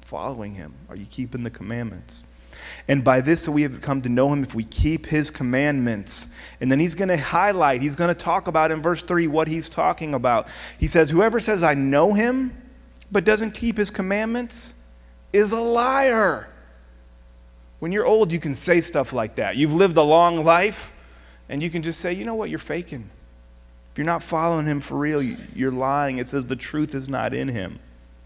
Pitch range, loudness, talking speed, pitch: 115-175 Hz, -22 LUFS, 200 wpm, 150 Hz